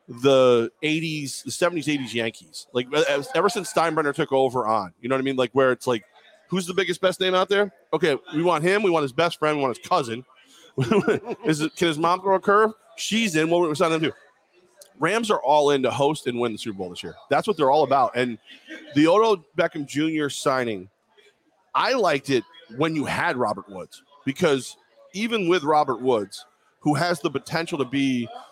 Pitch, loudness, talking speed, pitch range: 155 Hz, -23 LUFS, 215 wpm, 130-185 Hz